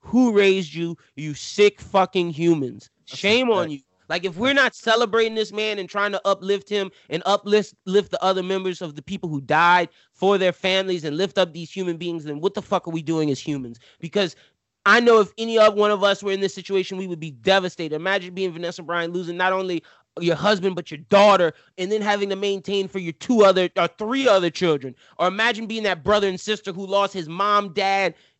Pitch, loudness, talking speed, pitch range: 190 Hz, -21 LUFS, 220 wpm, 170-205 Hz